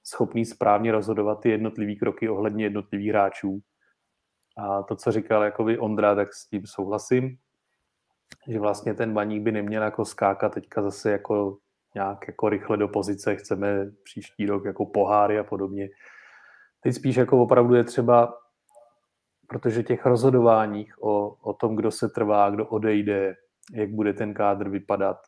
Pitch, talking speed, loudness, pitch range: 105 Hz, 150 wpm, -24 LUFS, 100-115 Hz